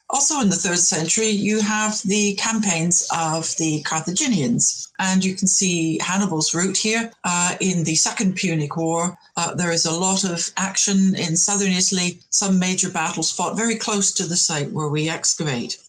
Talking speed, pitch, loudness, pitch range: 180 wpm, 185 Hz, -19 LUFS, 165-200 Hz